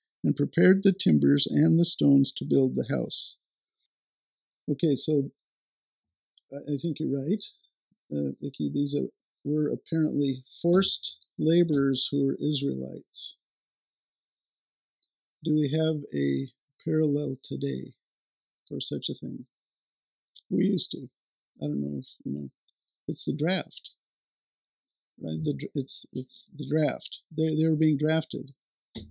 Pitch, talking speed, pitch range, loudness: 145 Hz, 125 wpm, 130-155 Hz, -27 LUFS